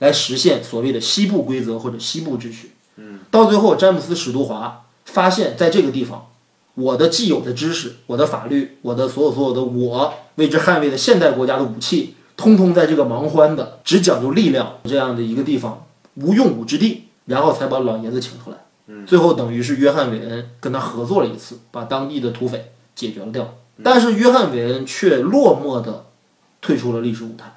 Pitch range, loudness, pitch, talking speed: 120-155 Hz, -17 LUFS, 130 Hz, 310 characters per minute